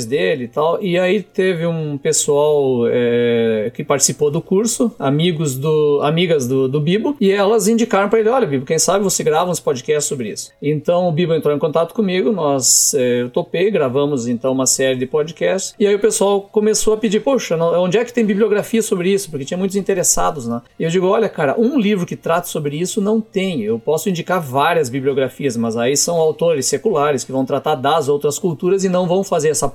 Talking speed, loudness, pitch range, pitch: 210 wpm, -16 LUFS, 145-205 Hz, 175 Hz